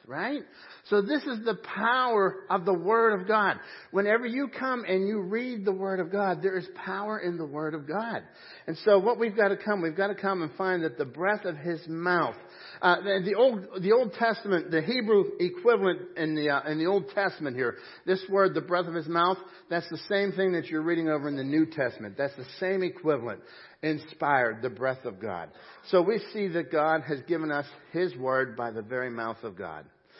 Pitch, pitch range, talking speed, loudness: 185 Hz, 155-205 Hz, 220 wpm, -28 LUFS